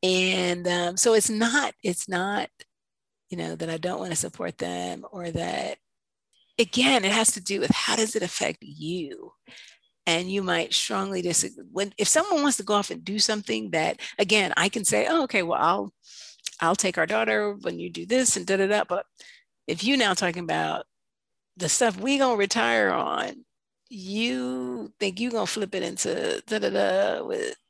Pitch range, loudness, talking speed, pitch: 175-230 Hz, -25 LUFS, 185 wpm, 200 Hz